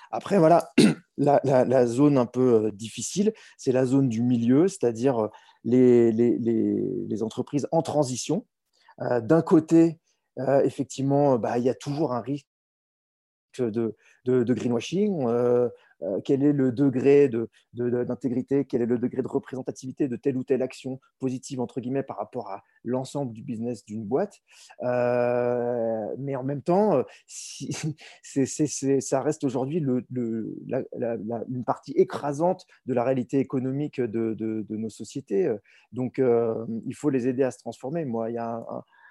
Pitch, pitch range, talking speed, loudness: 130 Hz, 120-140 Hz, 175 wpm, -25 LUFS